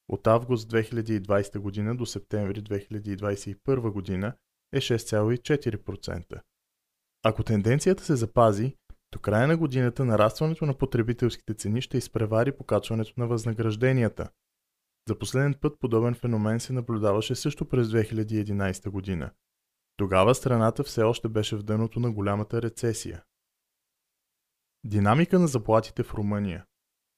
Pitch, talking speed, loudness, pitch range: 110 Hz, 115 wpm, -27 LUFS, 105-125 Hz